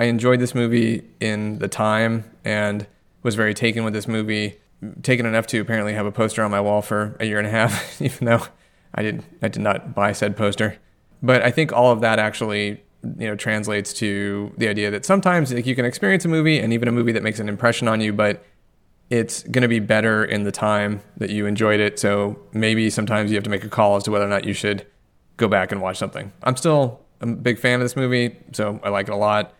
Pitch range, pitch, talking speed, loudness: 105-120 Hz, 110 Hz, 240 wpm, -21 LUFS